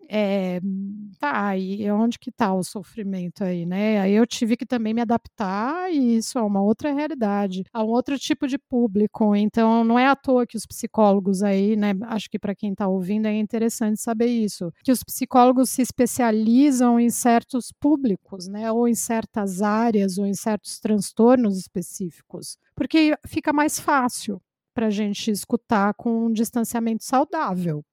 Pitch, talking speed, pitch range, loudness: 220 Hz, 170 wpm, 200-245 Hz, -22 LUFS